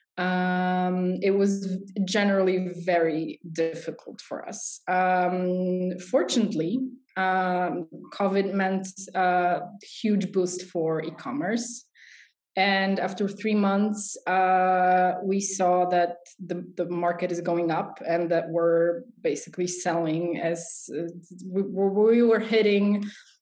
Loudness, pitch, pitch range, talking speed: -26 LUFS, 185 Hz, 175-195 Hz, 110 wpm